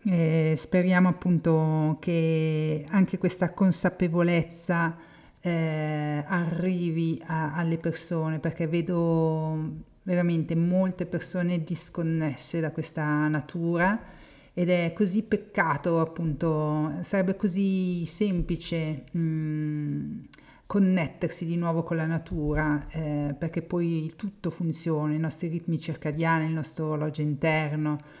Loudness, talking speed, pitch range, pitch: -27 LUFS, 105 wpm, 155-175 Hz, 165 Hz